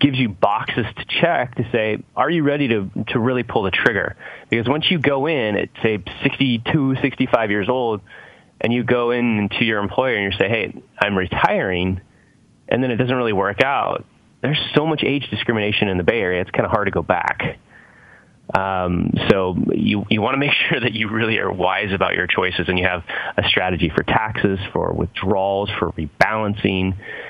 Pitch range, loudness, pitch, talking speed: 100-130 Hz, -19 LUFS, 110 Hz, 200 wpm